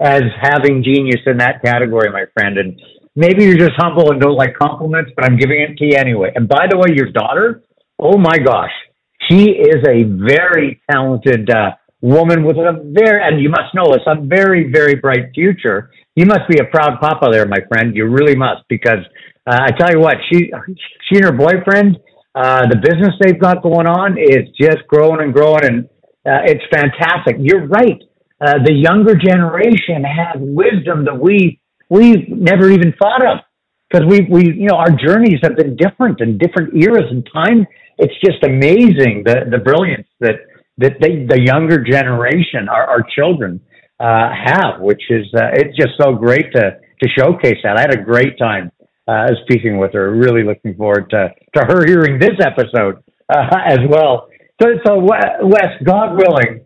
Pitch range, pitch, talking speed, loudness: 125-180 Hz, 150 Hz, 185 wpm, -11 LUFS